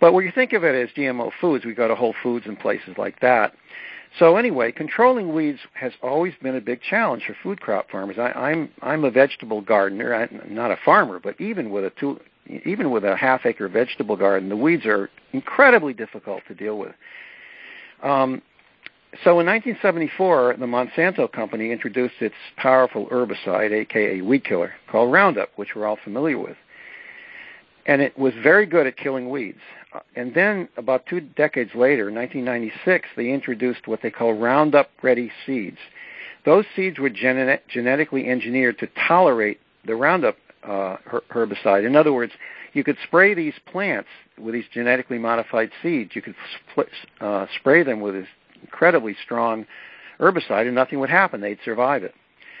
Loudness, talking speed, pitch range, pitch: -21 LUFS, 170 wpm, 115-170 Hz, 130 Hz